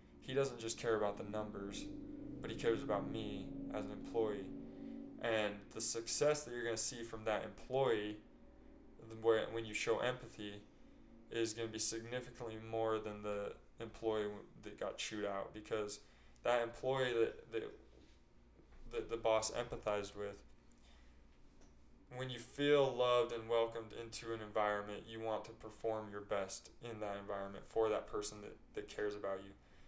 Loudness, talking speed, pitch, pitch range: -41 LUFS, 160 wpm, 110 Hz, 105-115 Hz